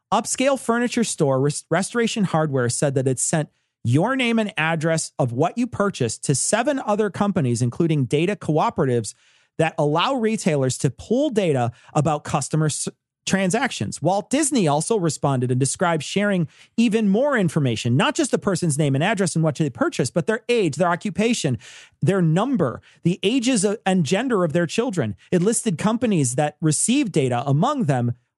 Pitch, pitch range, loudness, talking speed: 170 Hz, 145-215 Hz, -21 LUFS, 165 wpm